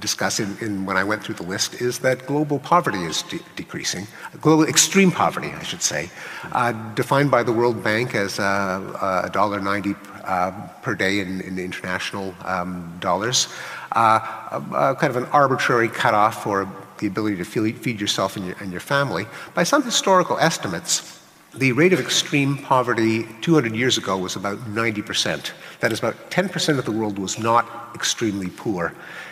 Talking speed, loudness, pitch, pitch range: 180 wpm, -21 LUFS, 110 Hz, 100-140 Hz